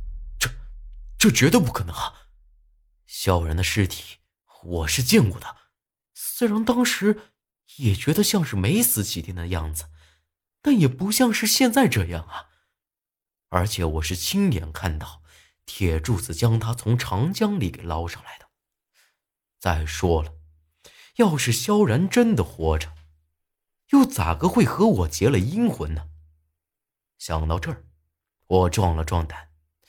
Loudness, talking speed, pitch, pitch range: -22 LUFS, 195 characters per minute, 90 Hz, 80-120 Hz